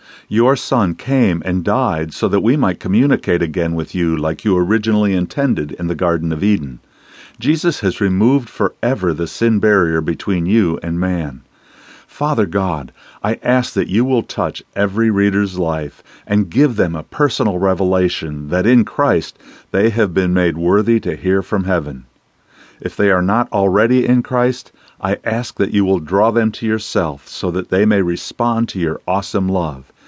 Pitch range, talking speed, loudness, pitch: 85-115 Hz, 175 wpm, -16 LUFS, 100 Hz